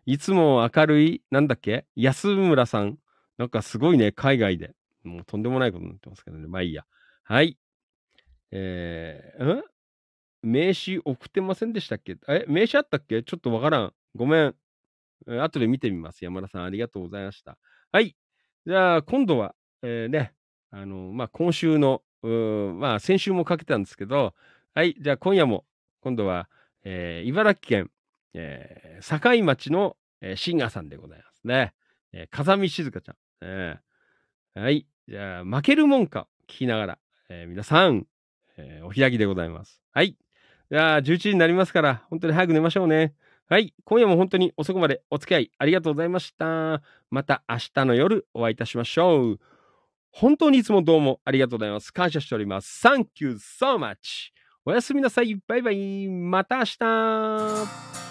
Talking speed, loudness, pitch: 350 characters per minute, -23 LUFS, 140 Hz